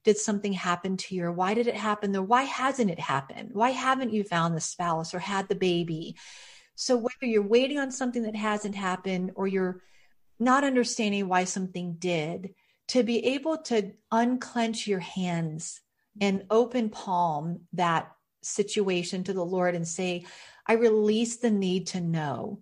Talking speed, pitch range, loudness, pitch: 165 wpm, 180-230 Hz, -28 LUFS, 200 Hz